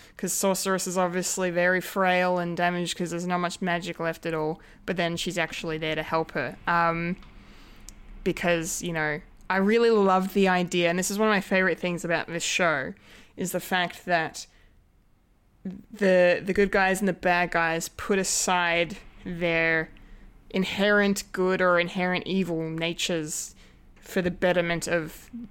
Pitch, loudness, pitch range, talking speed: 180 Hz, -25 LUFS, 170-190 Hz, 160 wpm